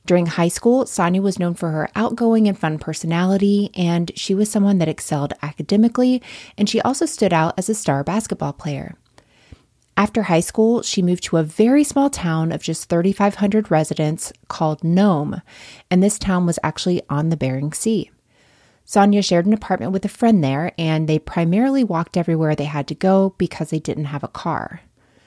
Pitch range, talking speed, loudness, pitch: 160-205 Hz, 185 wpm, -19 LUFS, 180 Hz